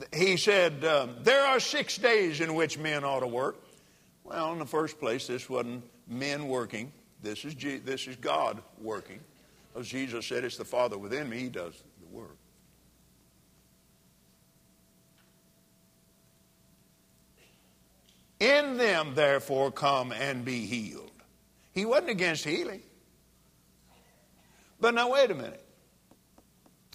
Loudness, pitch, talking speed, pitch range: -29 LUFS, 135 Hz, 125 wpm, 125-160 Hz